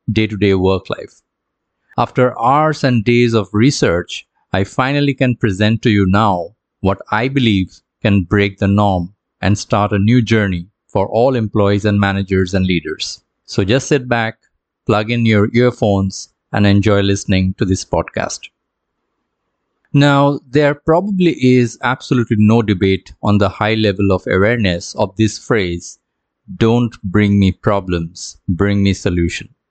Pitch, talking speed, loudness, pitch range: 105 Hz, 150 wpm, -15 LUFS, 95-120 Hz